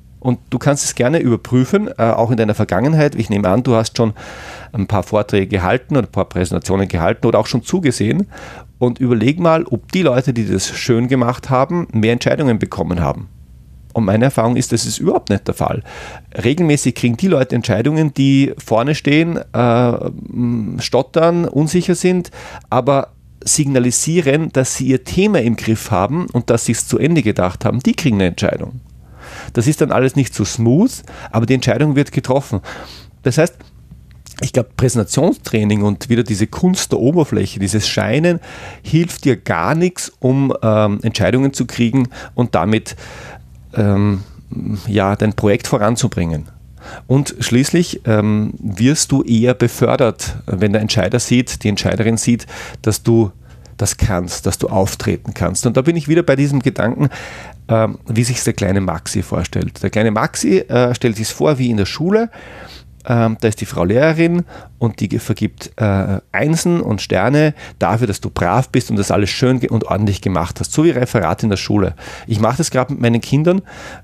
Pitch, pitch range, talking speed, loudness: 120 Hz, 105-135 Hz, 175 wpm, -16 LUFS